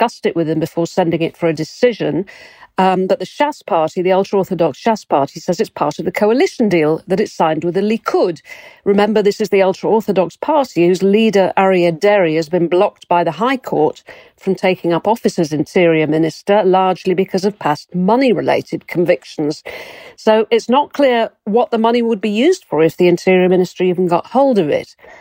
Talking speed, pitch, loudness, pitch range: 200 wpm, 190 Hz, -15 LUFS, 175-225 Hz